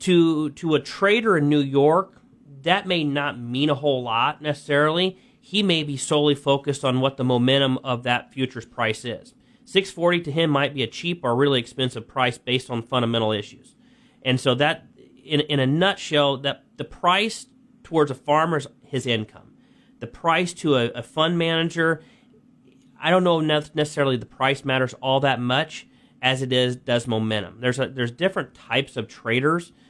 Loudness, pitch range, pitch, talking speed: -22 LUFS, 125-165 Hz, 140 Hz, 180 wpm